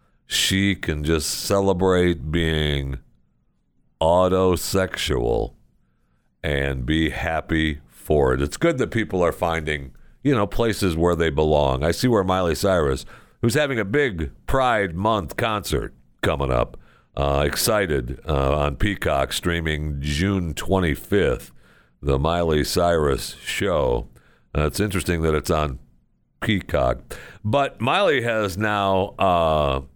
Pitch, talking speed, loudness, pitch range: 80 Hz, 120 wpm, -22 LUFS, 70-95 Hz